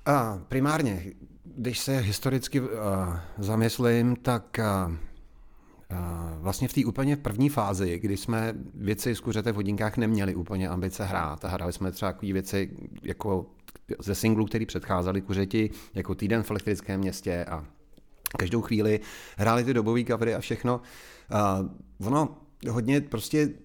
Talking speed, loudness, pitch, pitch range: 140 wpm, -28 LUFS, 105 Hz, 95-120 Hz